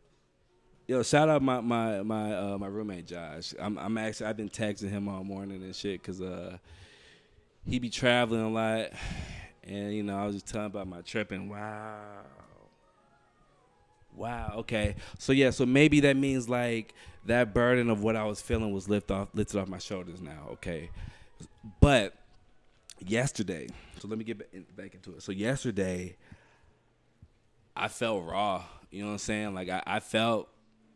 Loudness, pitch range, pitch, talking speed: -30 LUFS, 95-115 Hz, 105 Hz, 170 wpm